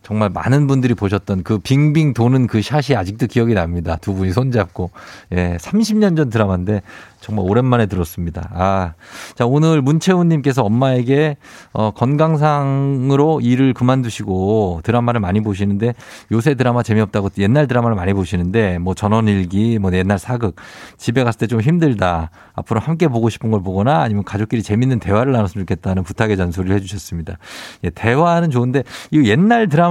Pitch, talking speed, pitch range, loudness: 110 Hz, 375 characters per minute, 100-135 Hz, -16 LUFS